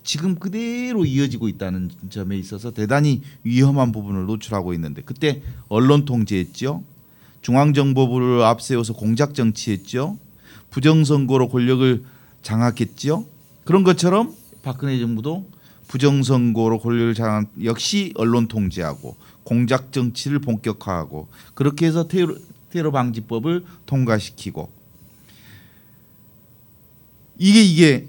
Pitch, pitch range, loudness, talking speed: 125 Hz, 110-145 Hz, -20 LUFS, 280 characters per minute